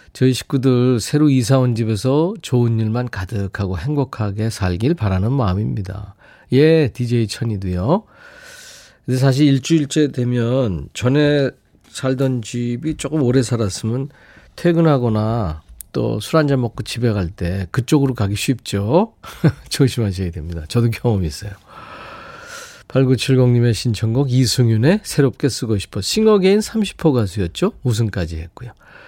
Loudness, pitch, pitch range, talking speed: -18 LUFS, 125 Hz, 105-140 Hz, 285 characters per minute